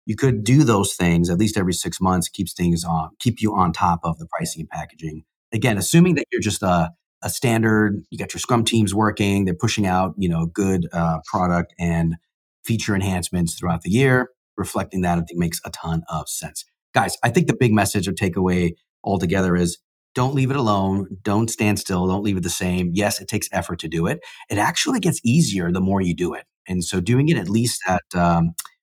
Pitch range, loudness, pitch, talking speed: 85-110 Hz, -21 LUFS, 95 Hz, 220 wpm